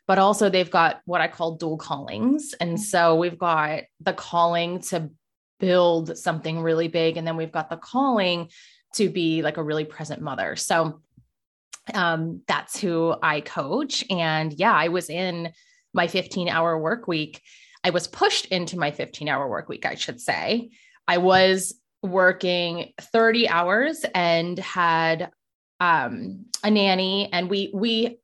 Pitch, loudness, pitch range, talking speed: 175 Hz, -23 LUFS, 165-200 Hz, 155 wpm